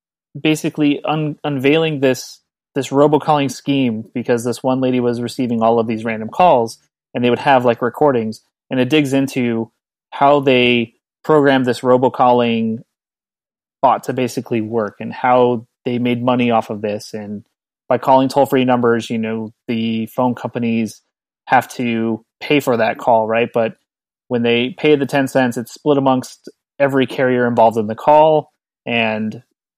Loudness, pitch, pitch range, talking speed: -16 LUFS, 125 Hz, 115-135 Hz, 160 wpm